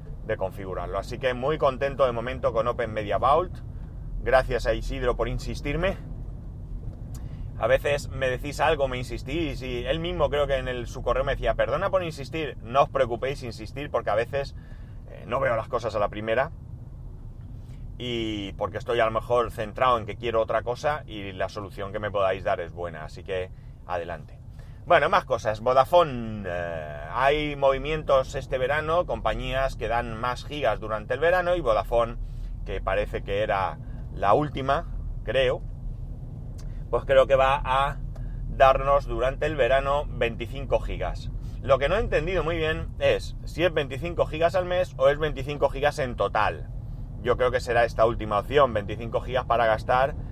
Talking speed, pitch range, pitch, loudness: 175 wpm, 110-140 Hz, 125 Hz, -26 LUFS